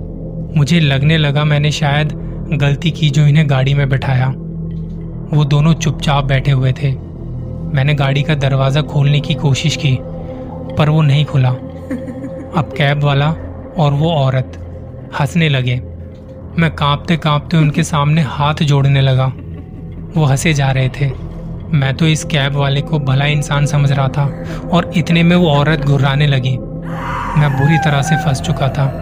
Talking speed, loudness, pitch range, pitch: 155 wpm, -14 LUFS, 135-155 Hz, 145 Hz